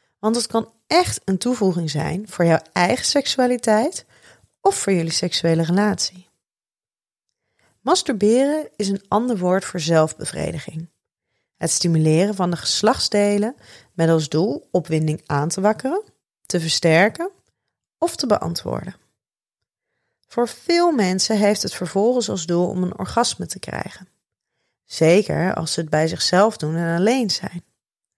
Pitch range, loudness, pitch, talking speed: 170-230 Hz, -20 LUFS, 195 Hz, 135 wpm